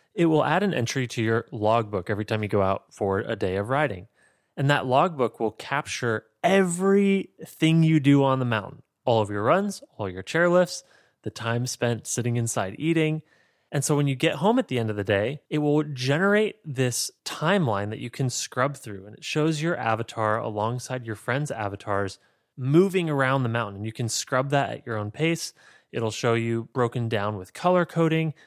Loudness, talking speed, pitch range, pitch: -25 LUFS, 200 wpm, 110-155 Hz, 125 Hz